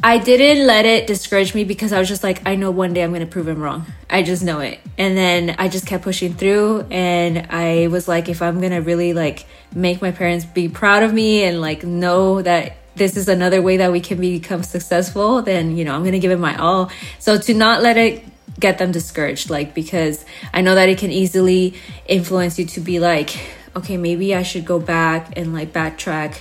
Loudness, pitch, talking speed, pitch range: -17 LUFS, 180 Hz, 230 wpm, 170-190 Hz